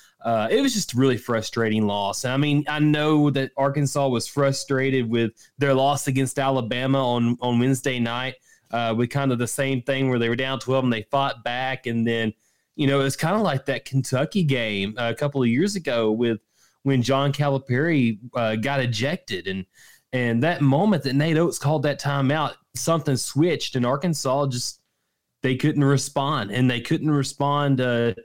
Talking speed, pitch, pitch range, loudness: 190 wpm, 135 Hz, 120-140 Hz, -23 LUFS